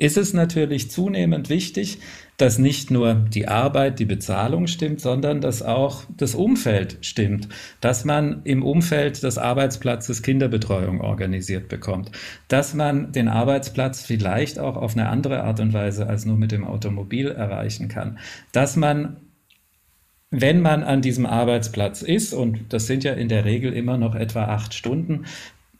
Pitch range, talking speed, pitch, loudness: 110-145 Hz, 155 wpm, 125 Hz, -22 LUFS